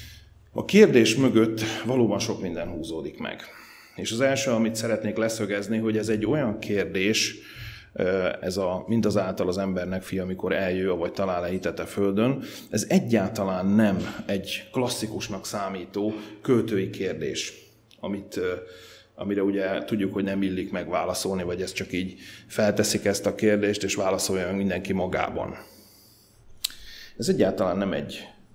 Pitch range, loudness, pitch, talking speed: 95-110 Hz, -26 LUFS, 100 Hz, 140 wpm